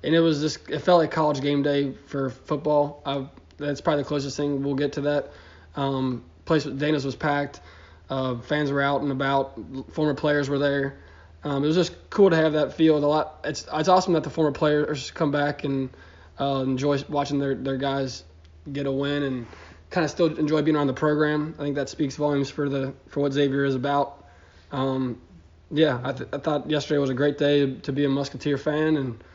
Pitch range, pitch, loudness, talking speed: 135-150 Hz, 140 Hz, -25 LUFS, 215 wpm